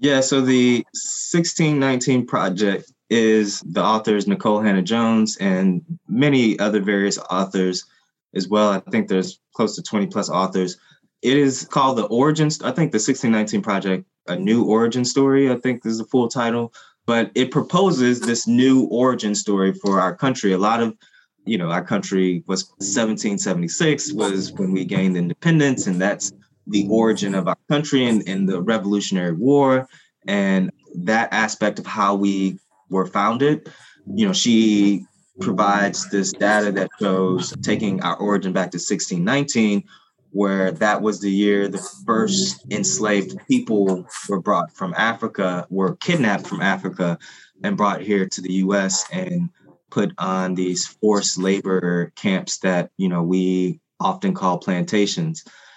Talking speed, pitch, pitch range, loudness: 150 wpm, 105 Hz, 95-135 Hz, -20 LUFS